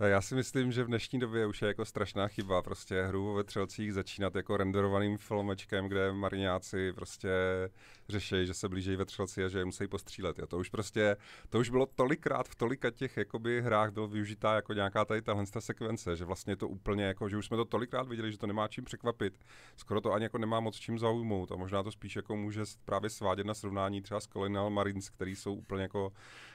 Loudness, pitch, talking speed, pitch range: -35 LUFS, 105 Hz, 215 wpm, 95-110 Hz